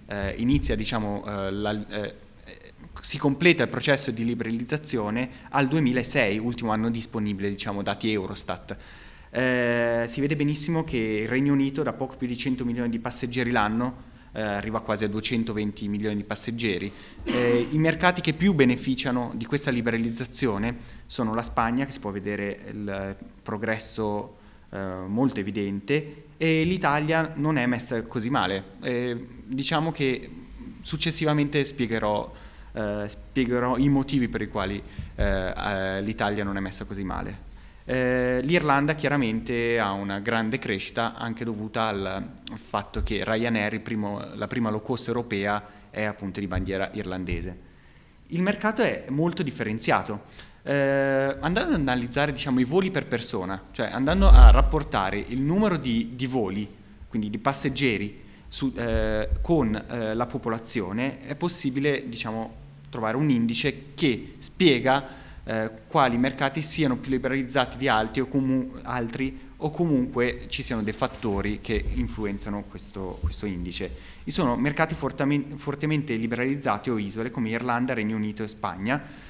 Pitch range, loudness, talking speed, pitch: 105-135 Hz, -26 LUFS, 145 wpm, 120 Hz